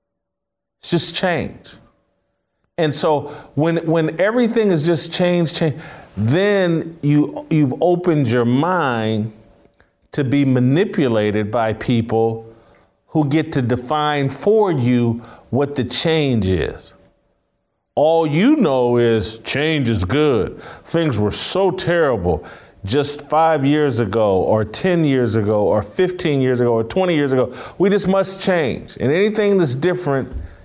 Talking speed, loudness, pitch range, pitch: 135 wpm, -17 LUFS, 115-170 Hz, 145 Hz